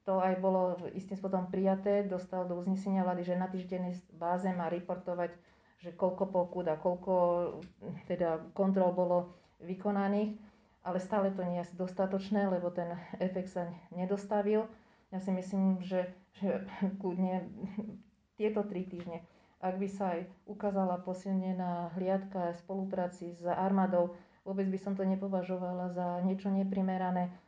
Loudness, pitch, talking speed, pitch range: -35 LUFS, 185 Hz, 140 wpm, 180-195 Hz